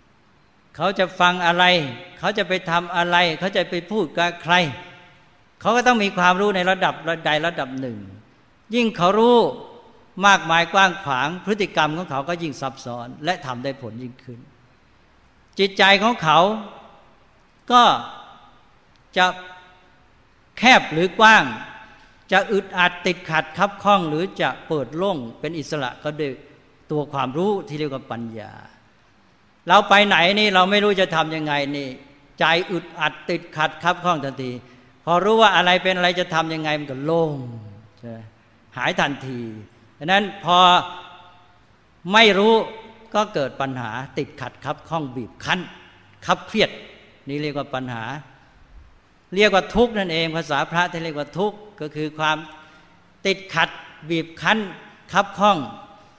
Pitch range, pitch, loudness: 140-195 Hz, 170 Hz, -19 LUFS